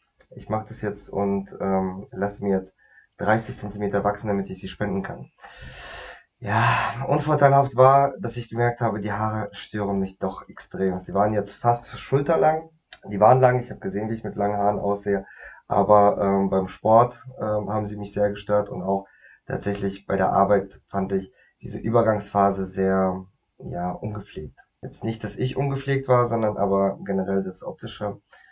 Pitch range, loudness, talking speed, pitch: 100-115 Hz, -23 LUFS, 170 wpm, 105 Hz